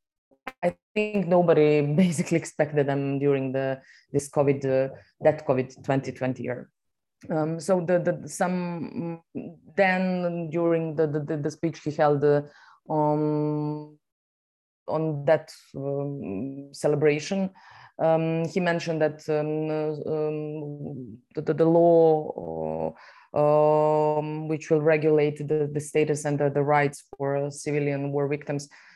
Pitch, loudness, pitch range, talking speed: 150 Hz, -25 LUFS, 145-160 Hz, 120 wpm